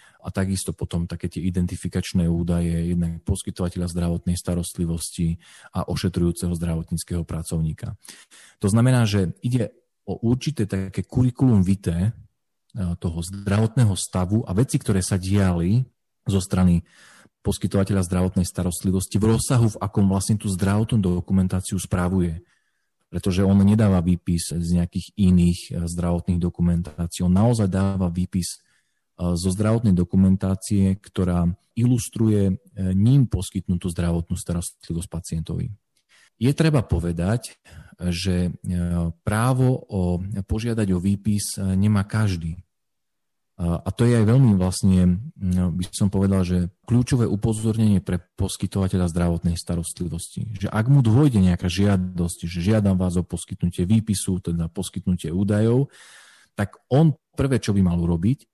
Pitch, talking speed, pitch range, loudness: 95 Hz, 120 wpm, 90-105 Hz, -22 LUFS